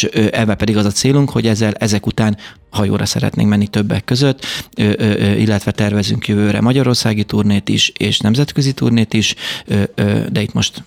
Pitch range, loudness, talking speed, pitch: 105-115 Hz, -15 LUFS, 150 wpm, 110 Hz